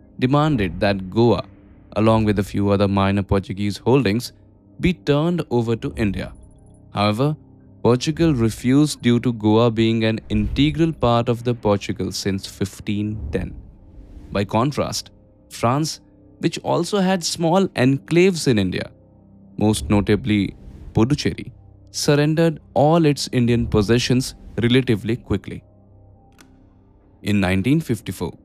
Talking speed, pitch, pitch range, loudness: 110 wpm, 105 Hz, 100-130 Hz, -20 LUFS